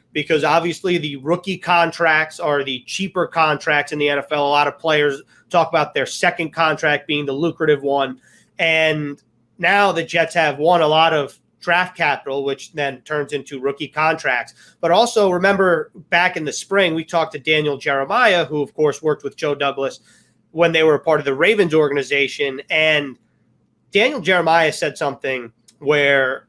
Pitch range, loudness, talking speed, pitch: 140-170 Hz, -18 LUFS, 170 wpm, 155 Hz